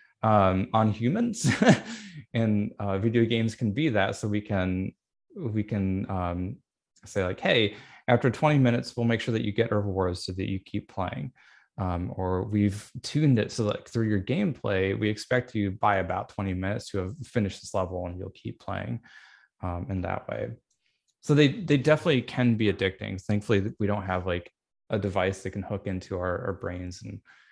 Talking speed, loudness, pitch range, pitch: 190 wpm, -27 LUFS, 95-120 Hz, 105 Hz